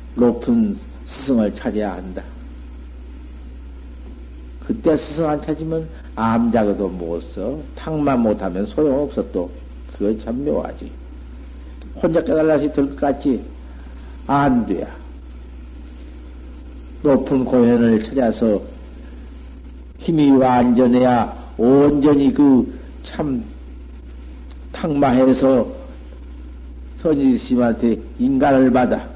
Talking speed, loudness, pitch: 175 characters per minute, -18 LUFS, 70 Hz